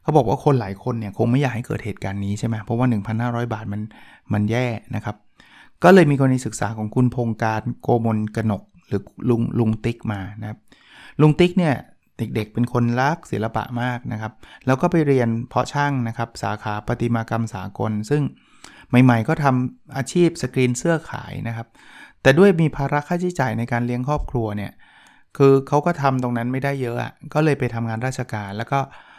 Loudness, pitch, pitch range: -21 LUFS, 120 Hz, 110-140 Hz